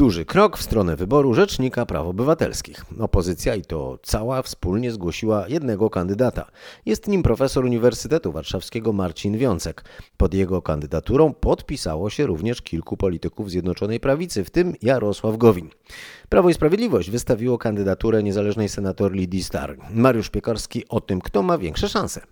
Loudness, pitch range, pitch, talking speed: -22 LUFS, 95-125 Hz, 110 Hz, 145 wpm